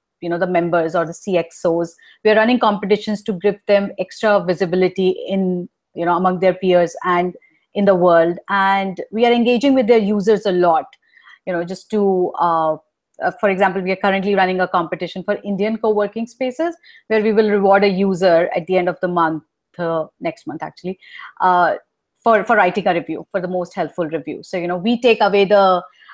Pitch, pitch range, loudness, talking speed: 190 Hz, 180-210 Hz, -17 LUFS, 195 wpm